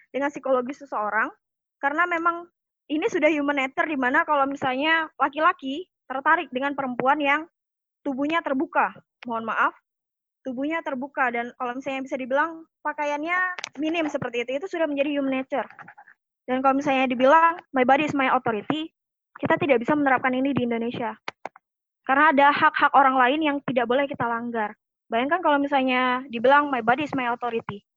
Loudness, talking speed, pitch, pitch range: -23 LUFS, 155 wpm, 275 Hz, 255-305 Hz